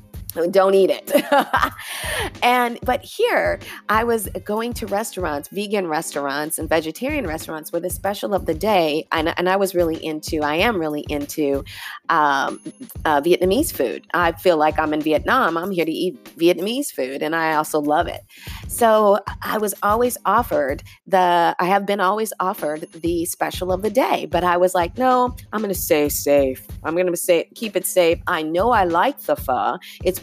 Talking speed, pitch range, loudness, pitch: 180 wpm, 155-215 Hz, -20 LUFS, 180 Hz